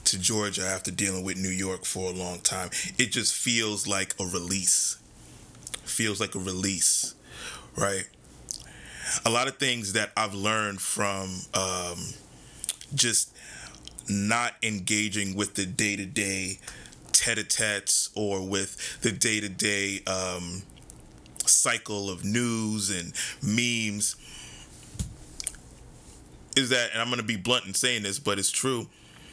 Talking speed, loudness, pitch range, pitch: 130 wpm, -25 LUFS, 95-115 Hz, 100 Hz